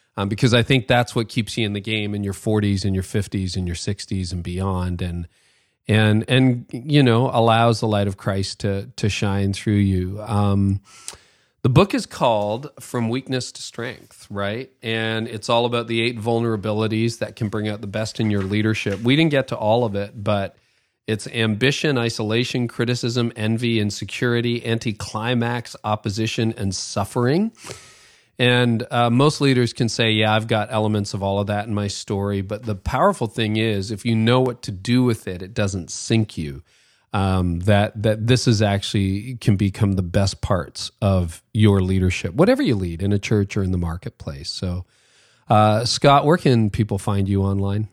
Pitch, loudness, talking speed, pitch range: 110 Hz, -21 LUFS, 185 wpm, 100-120 Hz